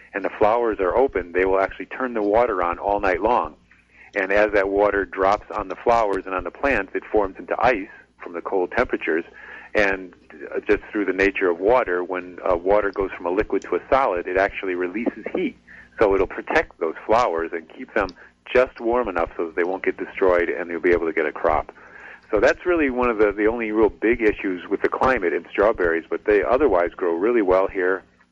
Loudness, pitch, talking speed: -21 LUFS, 110 Hz, 225 wpm